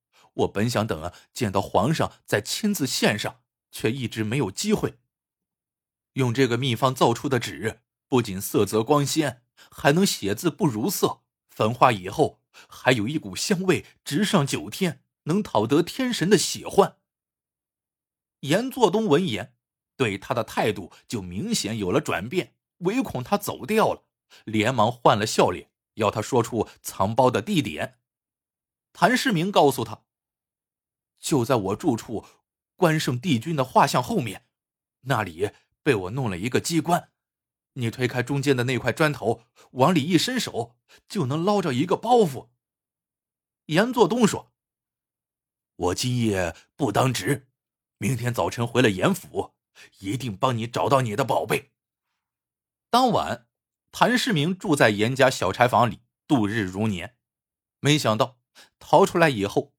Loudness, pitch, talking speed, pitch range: -24 LUFS, 130 Hz, 210 characters per minute, 115-160 Hz